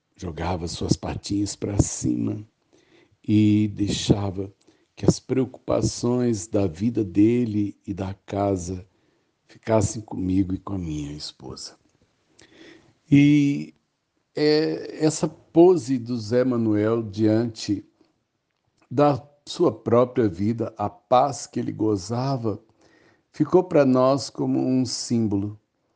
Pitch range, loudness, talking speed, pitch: 100-125 Hz, -23 LUFS, 105 wpm, 110 Hz